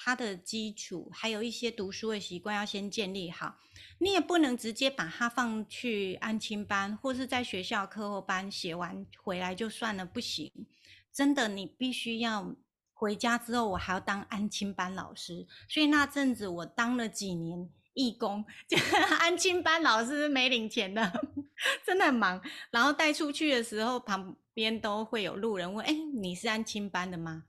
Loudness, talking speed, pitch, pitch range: -31 LUFS, 255 characters per minute, 220 Hz, 195-250 Hz